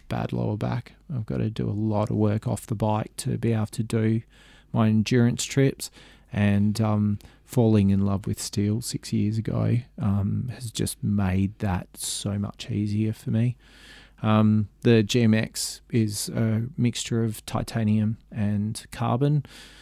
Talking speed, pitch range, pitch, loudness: 155 wpm, 105-115 Hz, 110 Hz, -25 LUFS